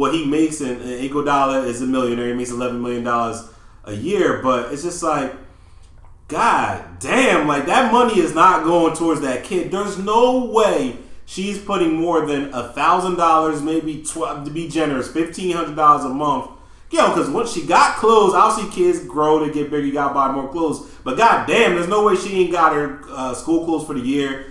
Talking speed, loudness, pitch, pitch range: 215 wpm, -18 LUFS, 150 Hz, 130-170 Hz